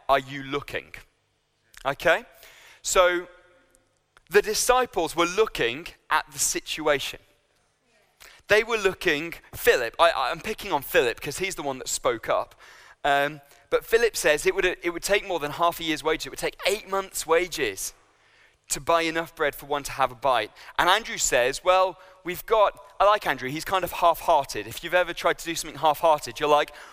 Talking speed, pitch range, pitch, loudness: 185 wpm, 150-200 Hz, 175 Hz, -24 LUFS